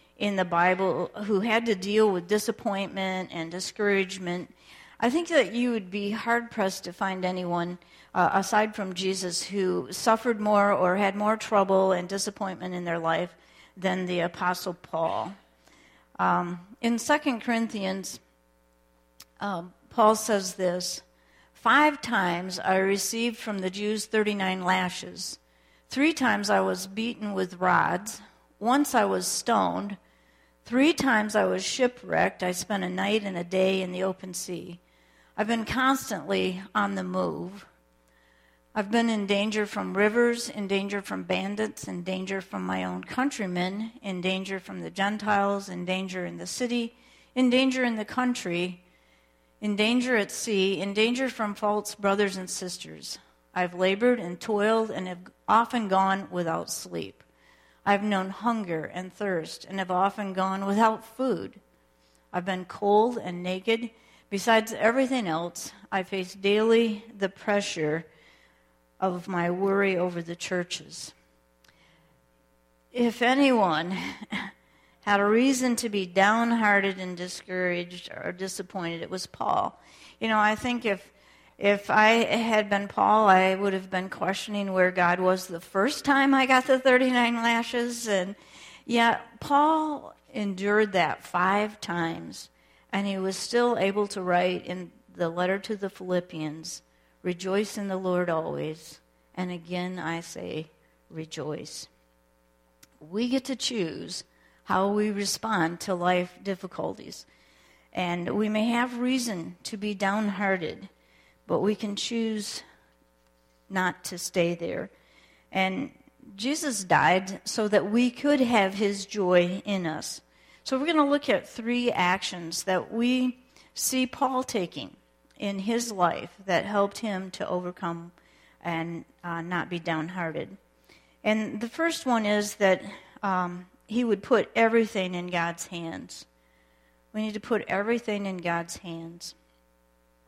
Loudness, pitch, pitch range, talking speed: -27 LUFS, 190 Hz, 175-215 Hz, 140 wpm